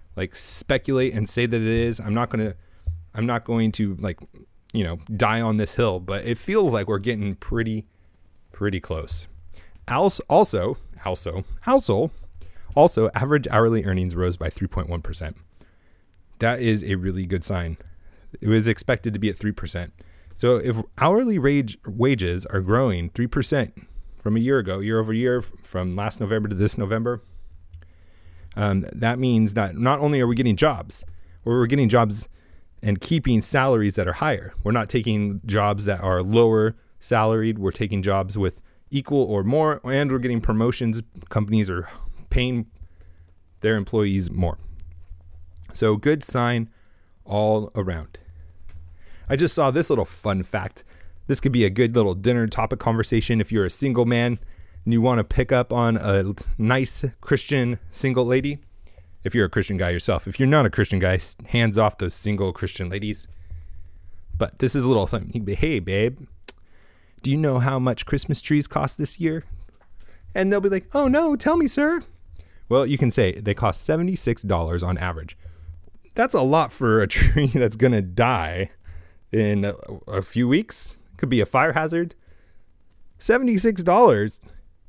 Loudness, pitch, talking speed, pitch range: -22 LUFS, 105 Hz, 165 wpm, 90-120 Hz